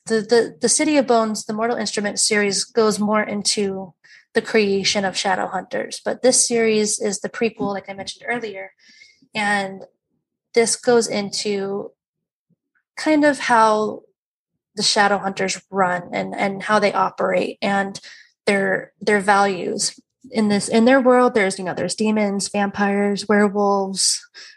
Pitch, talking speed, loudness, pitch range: 210 Hz, 145 wpm, -19 LUFS, 195-230 Hz